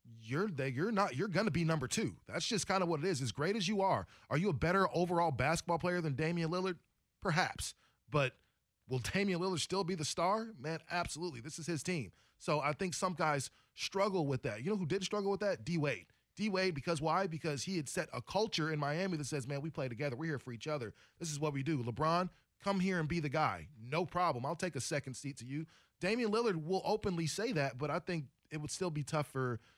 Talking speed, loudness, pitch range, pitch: 245 wpm, -37 LUFS, 145-185 Hz, 165 Hz